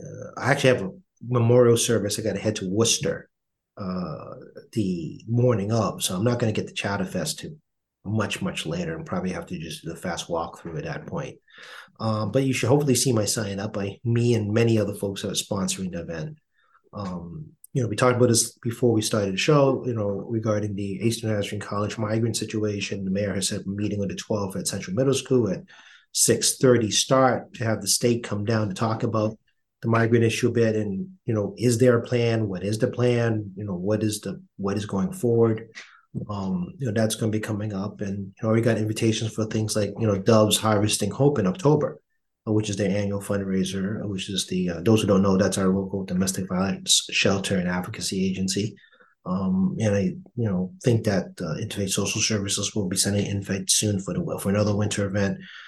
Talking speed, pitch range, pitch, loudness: 220 wpm, 100-120 Hz, 110 Hz, -24 LUFS